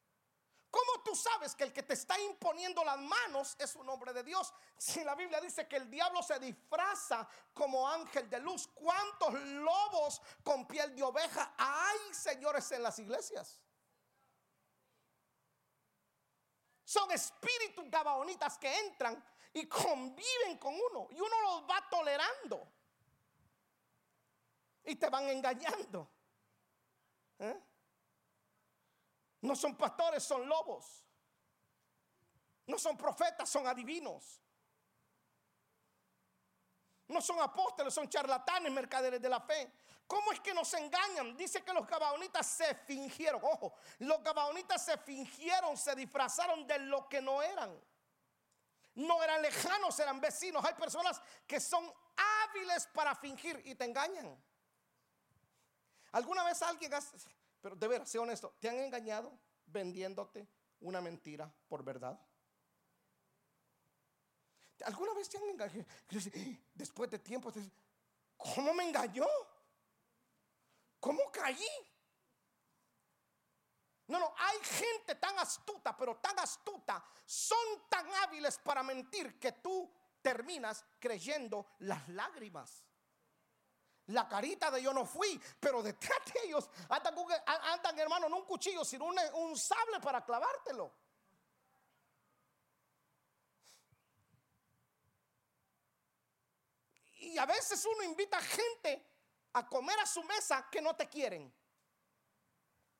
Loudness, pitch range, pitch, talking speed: -38 LUFS, 265-360 Hz, 305 Hz, 120 wpm